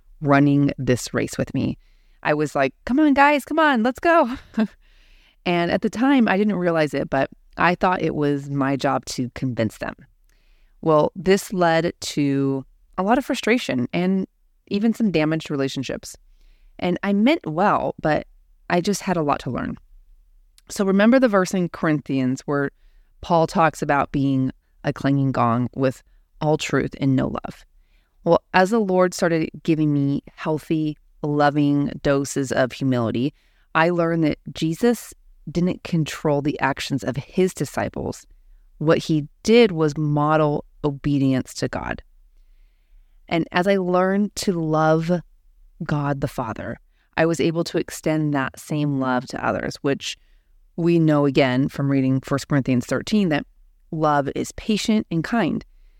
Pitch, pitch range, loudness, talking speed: 155 Hz, 135-180 Hz, -21 LUFS, 155 wpm